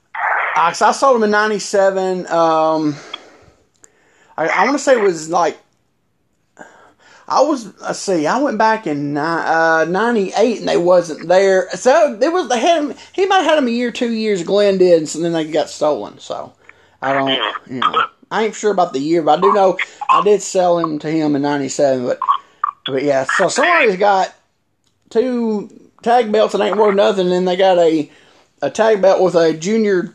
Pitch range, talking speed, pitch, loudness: 160-230 Hz, 200 wpm, 190 Hz, -15 LUFS